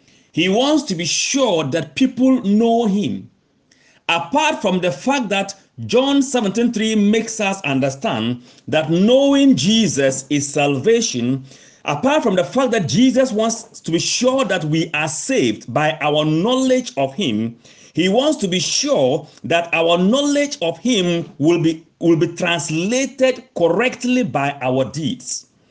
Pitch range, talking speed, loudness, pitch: 155-245 Hz, 145 wpm, -17 LUFS, 190 Hz